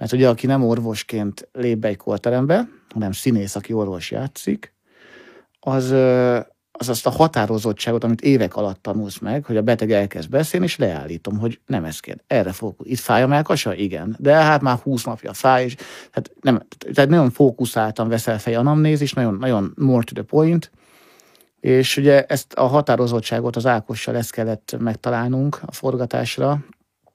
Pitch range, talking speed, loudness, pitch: 110-135 Hz, 165 wpm, -19 LUFS, 120 Hz